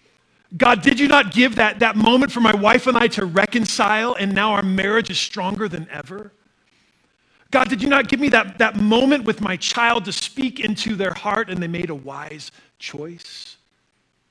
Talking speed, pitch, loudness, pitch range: 195 wpm, 215 Hz, -18 LUFS, 190-240 Hz